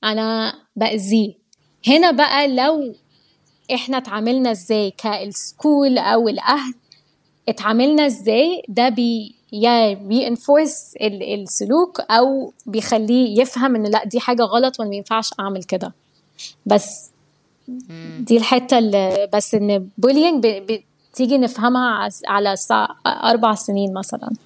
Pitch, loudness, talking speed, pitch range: 225 Hz, -17 LUFS, 105 wpm, 205-255 Hz